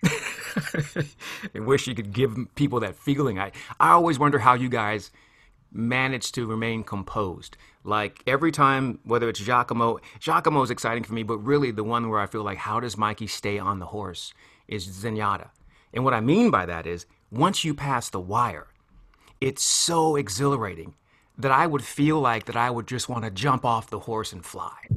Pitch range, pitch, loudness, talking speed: 105-135 Hz, 120 Hz, -25 LUFS, 190 wpm